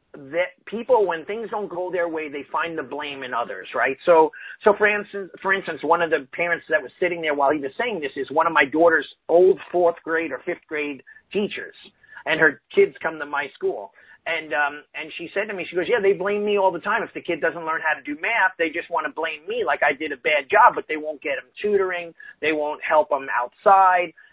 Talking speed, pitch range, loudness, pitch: 250 wpm, 155-200 Hz, -22 LUFS, 170 Hz